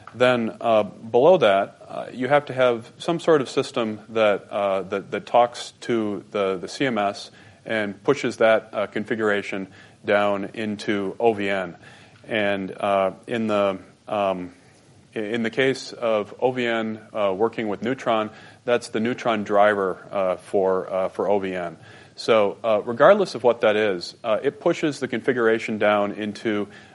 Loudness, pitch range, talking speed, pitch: -23 LUFS, 100-120 Hz, 150 wpm, 110 Hz